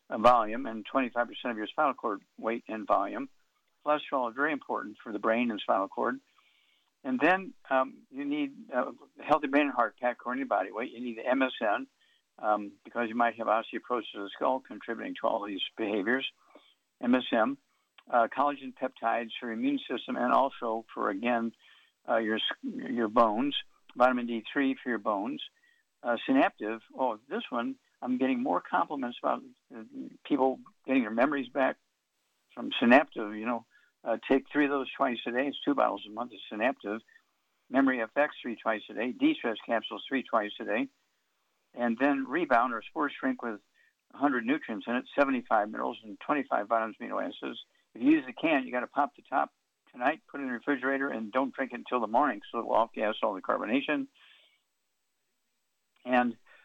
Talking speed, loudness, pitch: 180 wpm, -30 LUFS, 135 Hz